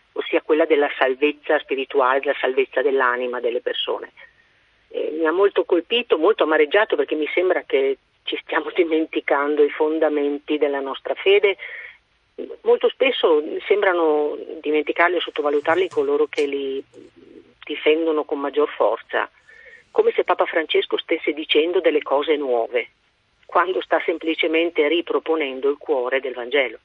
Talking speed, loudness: 130 wpm, -20 LUFS